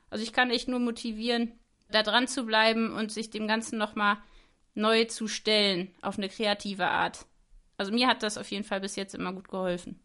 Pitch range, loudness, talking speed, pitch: 200-235 Hz, -28 LUFS, 210 wpm, 220 Hz